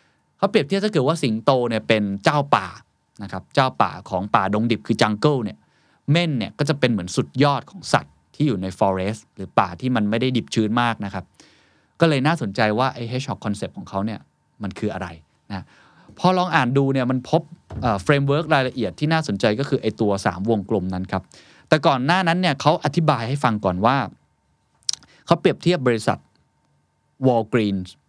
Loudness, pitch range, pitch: -21 LUFS, 105-150 Hz, 125 Hz